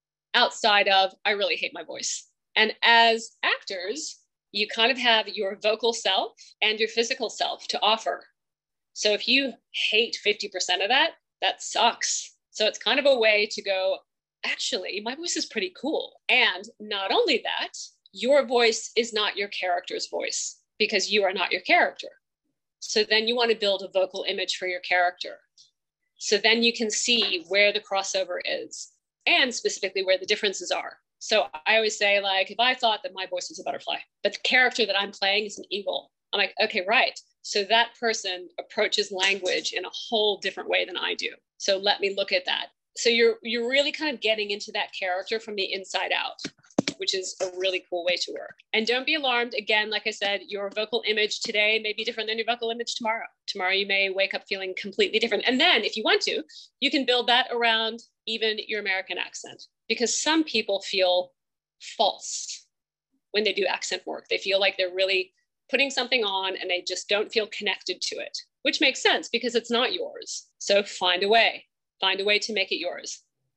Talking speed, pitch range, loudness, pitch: 200 wpm, 195-240 Hz, -24 LUFS, 215 Hz